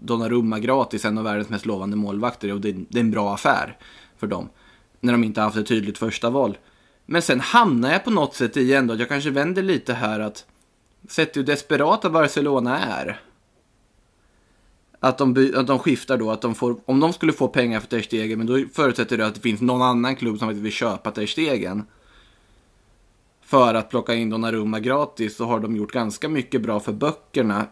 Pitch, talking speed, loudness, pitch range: 115 Hz, 195 wpm, -22 LUFS, 105-130 Hz